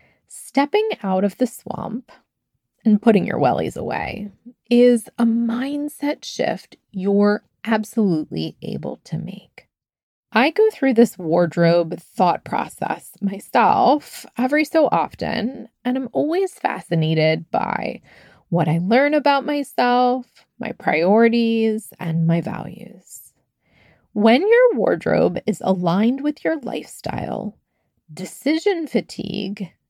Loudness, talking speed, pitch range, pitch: -20 LUFS, 110 wpm, 190-255 Hz, 225 Hz